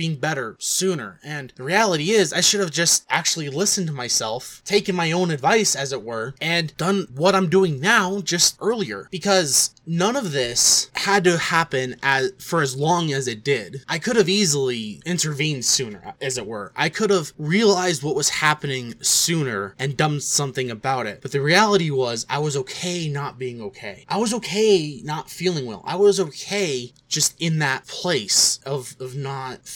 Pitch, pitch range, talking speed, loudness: 155 Hz, 135-190 Hz, 185 wpm, -20 LUFS